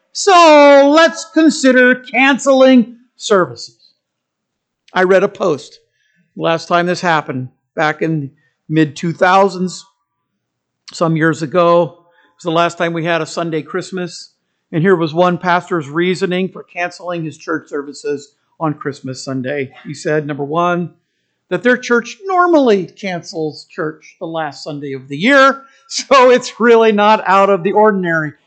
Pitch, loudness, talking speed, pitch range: 175 Hz, -13 LUFS, 145 wpm, 160-215 Hz